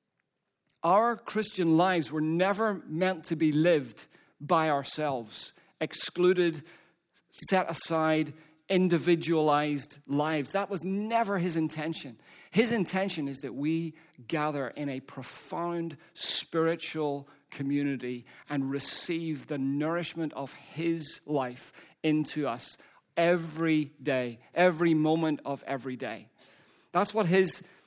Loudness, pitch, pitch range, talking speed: -29 LUFS, 160 Hz, 145-175 Hz, 110 wpm